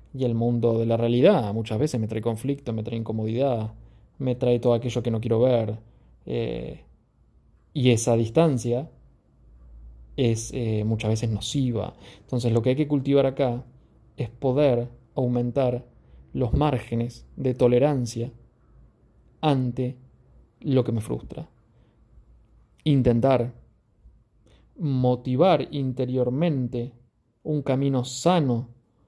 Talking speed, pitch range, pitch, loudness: 115 wpm, 115-130 Hz, 120 Hz, -24 LUFS